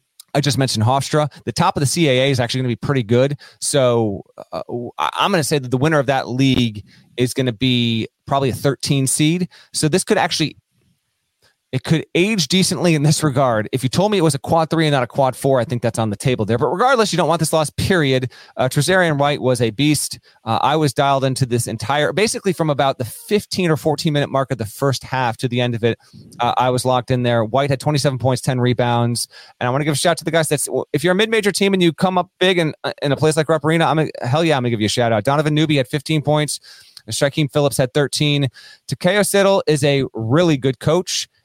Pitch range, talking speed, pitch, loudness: 125-160 Hz, 255 wpm, 140 Hz, -18 LUFS